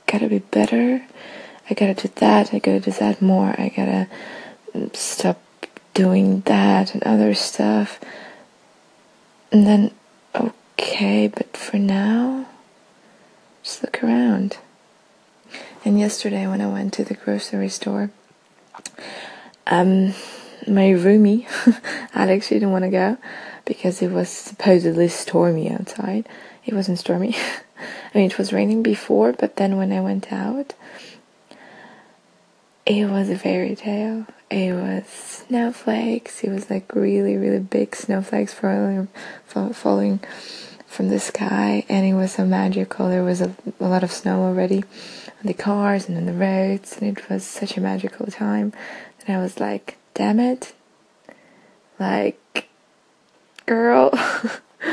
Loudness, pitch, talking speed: -20 LUFS, 195 Hz, 135 wpm